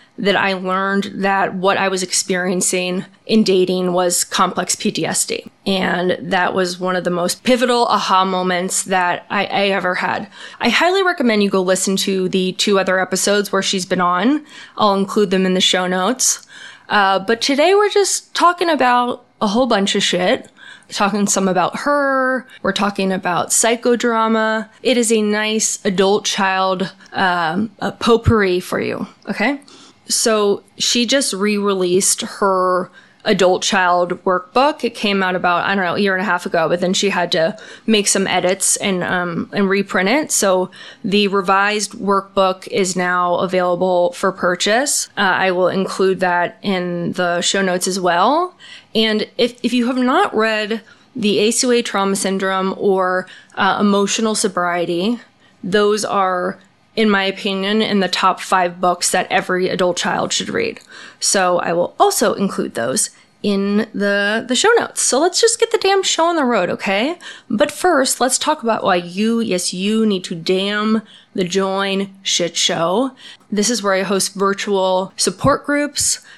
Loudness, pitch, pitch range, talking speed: -16 LUFS, 195 Hz, 185-225 Hz, 165 wpm